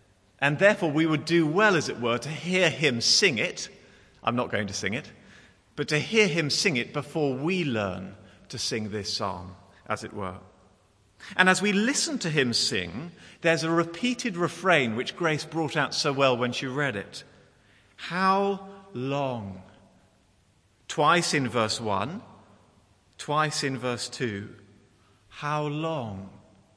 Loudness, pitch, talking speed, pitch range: -26 LUFS, 130 Hz, 155 wpm, 105-165 Hz